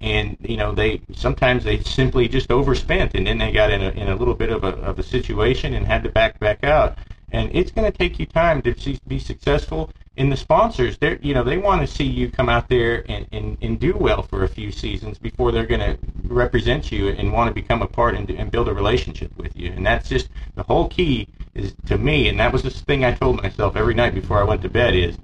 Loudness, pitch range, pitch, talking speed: -20 LUFS, 105-125 Hz, 115 Hz, 255 wpm